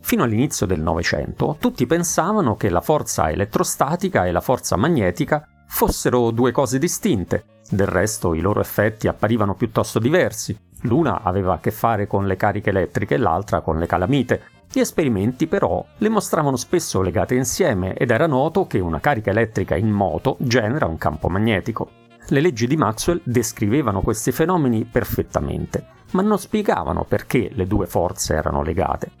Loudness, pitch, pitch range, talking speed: -20 LUFS, 115 Hz, 95-140 Hz, 160 wpm